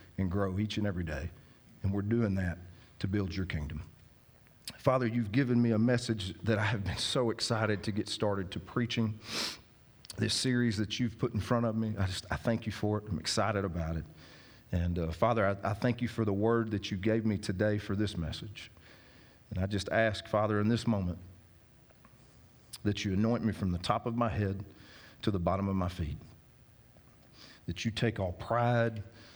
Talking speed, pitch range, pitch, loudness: 200 wpm, 95-115 Hz, 105 Hz, -33 LUFS